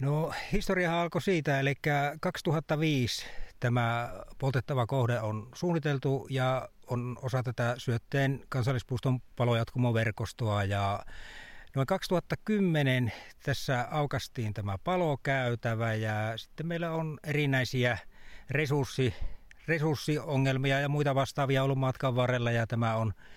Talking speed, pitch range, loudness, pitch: 105 wpm, 120-150 Hz, -31 LUFS, 130 Hz